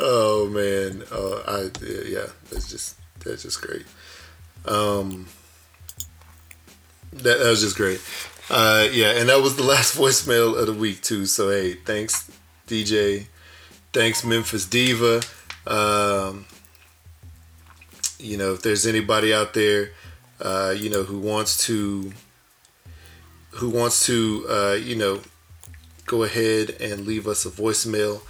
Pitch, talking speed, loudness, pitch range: 100 Hz, 135 wpm, -21 LUFS, 85-110 Hz